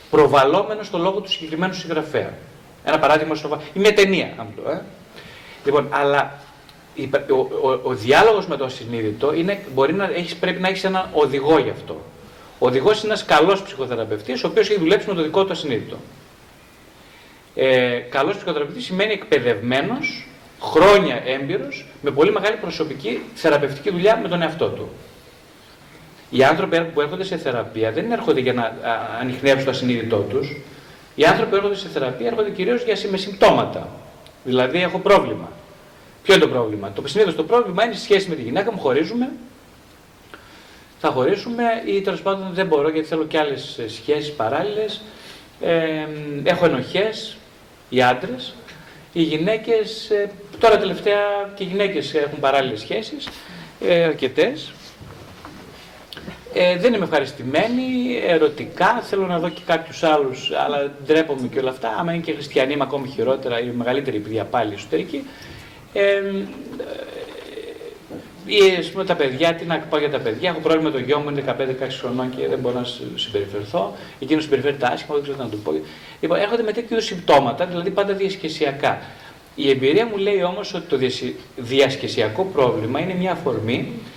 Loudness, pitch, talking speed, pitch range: -20 LUFS, 170 Hz, 160 wpm, 140-200 Hz